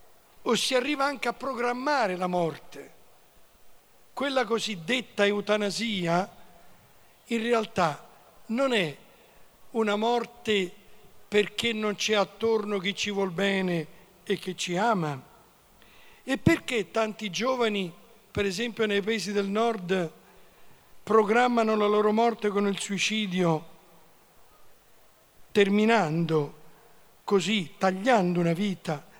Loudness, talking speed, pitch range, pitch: -27 LUFS, 105 wpm, 185-230 Hz, 205 Hz